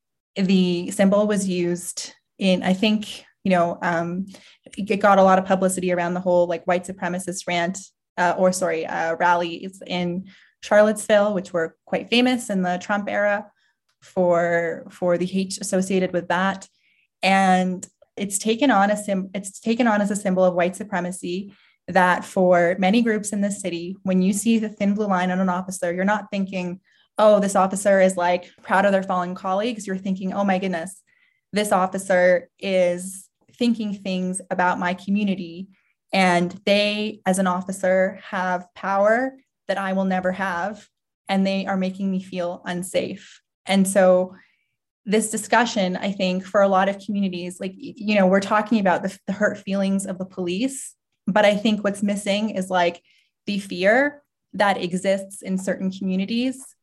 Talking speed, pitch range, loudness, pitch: 170 wpm, 180-205 Hz, -22 LUFS, 190 Hz